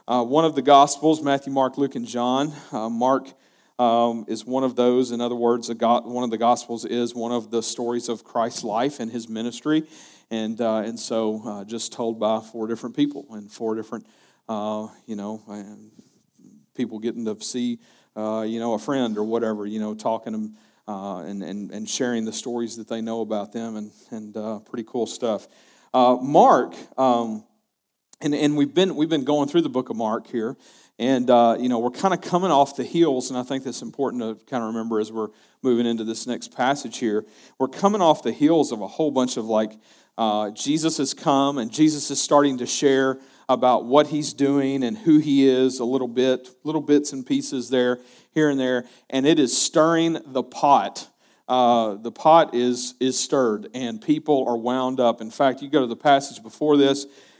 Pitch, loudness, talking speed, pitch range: 125 Hz, -22 LUFS, 210 wpm, 115-140 Hz